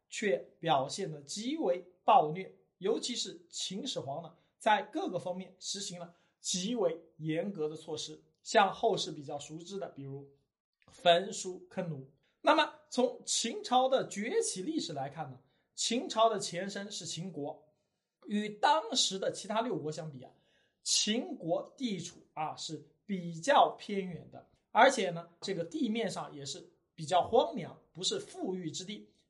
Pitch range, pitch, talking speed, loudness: 160-225 Hz, 185 Hz, 220 characters per minute, -33 LUFS